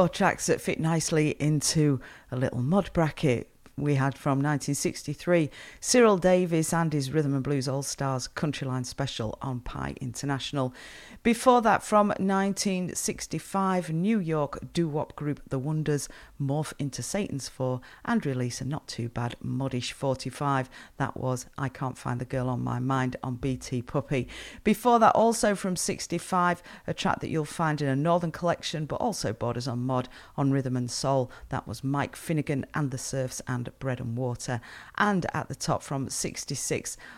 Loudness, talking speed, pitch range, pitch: -28 LUFS, 165 wpm, 130-170 Hz, 140 Hz